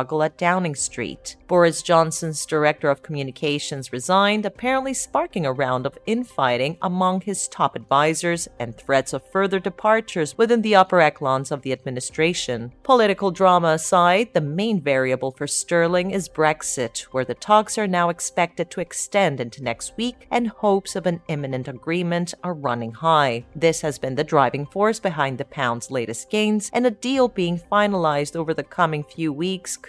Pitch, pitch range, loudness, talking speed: 165 Hz, 140-195 Hz, -21 LUFS, 165 wpm